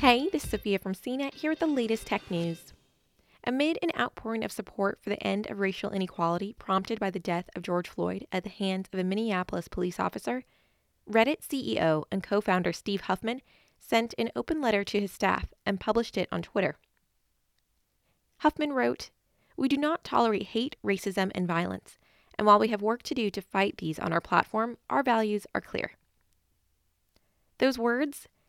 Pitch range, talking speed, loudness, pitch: 180-235 Hz, 180 wpm, -29 LUFS, 200 Hz